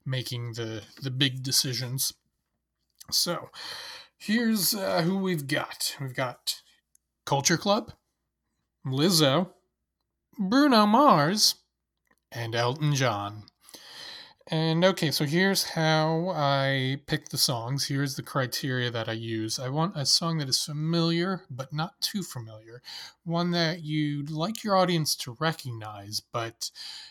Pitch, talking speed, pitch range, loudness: 155 Hz, 125 wpm, 130-180 Hz, -26 LUFS